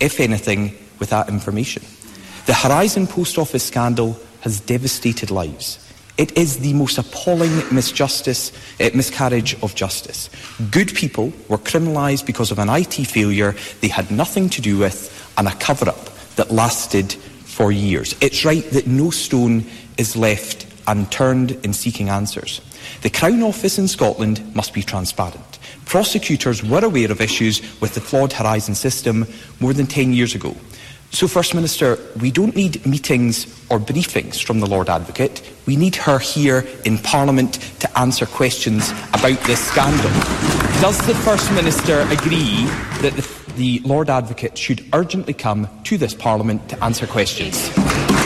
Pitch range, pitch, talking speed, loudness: 105-140 Hz, 120 Hz, 155 wpm, -18 LUFS